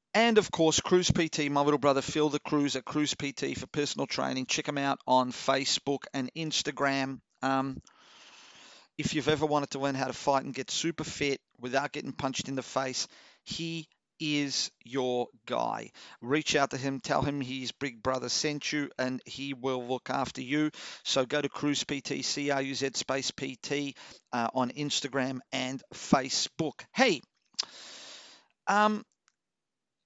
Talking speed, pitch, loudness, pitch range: 165 wpm, 140 Hz, -30 LUFS, 130-150 Hz